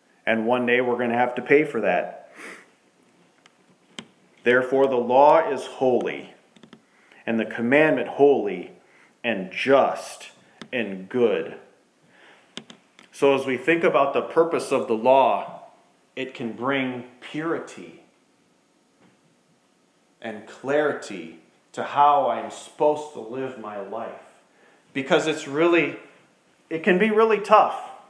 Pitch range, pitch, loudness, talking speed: 120-155 Hz, 135 Hz, -22 LUFS, 120 wpm